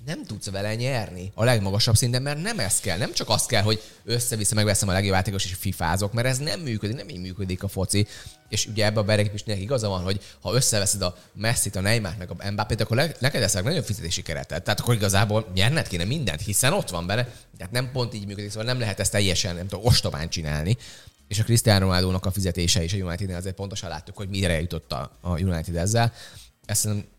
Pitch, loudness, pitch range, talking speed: 105 Hz, -24 LUFS, 95-115 Hz, 225 wpm